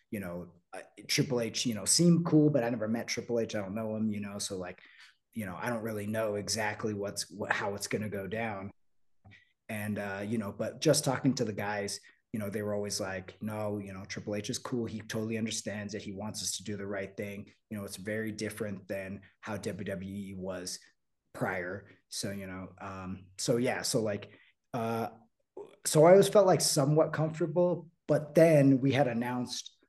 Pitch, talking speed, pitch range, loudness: 110 Hz, 205 wpm, 100-125 Hz, -31 LUFS